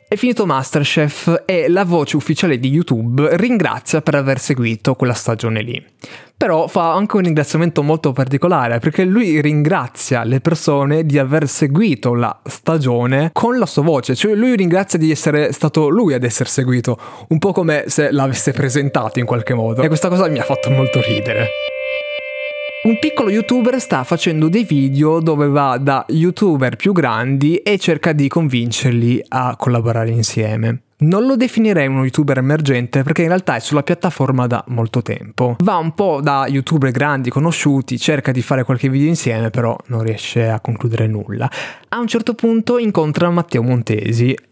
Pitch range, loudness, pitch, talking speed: 125-170 Hz, -16 LUFS, 145 Hz, 170 wpm